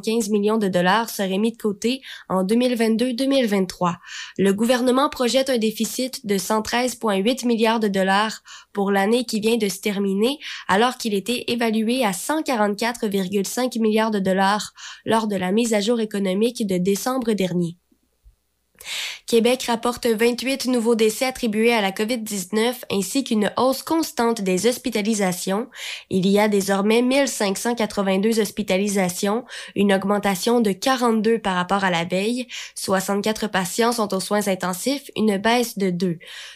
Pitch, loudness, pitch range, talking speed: 220 Hz, -21 LUFS, 195-240 Hz, 140 wpm